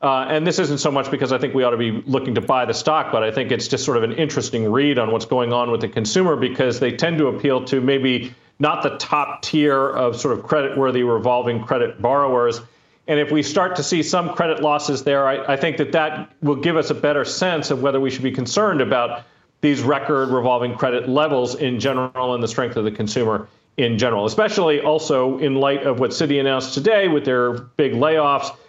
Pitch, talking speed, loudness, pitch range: 135 Hz, 230 wpm, -19 LUFS, 125-150 Hz